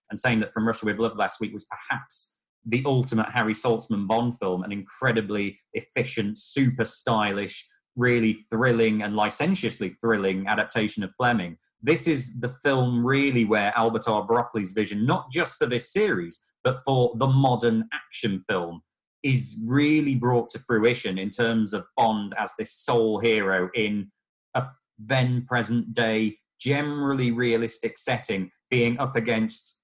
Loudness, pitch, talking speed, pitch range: -25 LUFS, 115 Hz, 145 wpm, 110-125 Hz